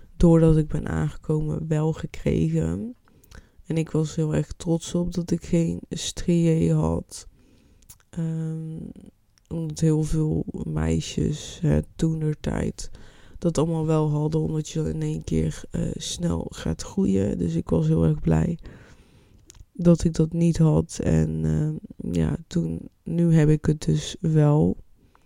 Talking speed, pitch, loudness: 140 wpm, 155 Hz, -24 LUFS